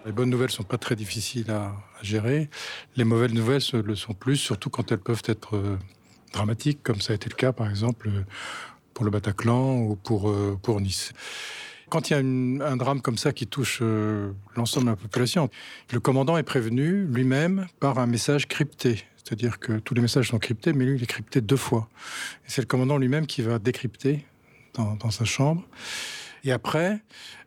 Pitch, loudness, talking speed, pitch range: 120 Hz, -26 LUFS, 205 wpm, 110-135 Hz